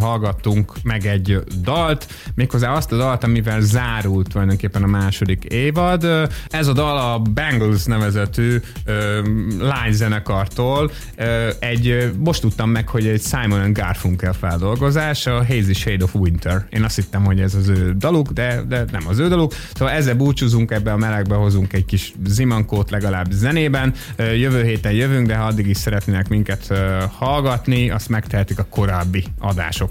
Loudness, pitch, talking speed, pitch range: -18 LUFS, 110 Hz, 155 wpm, 100-125 Hz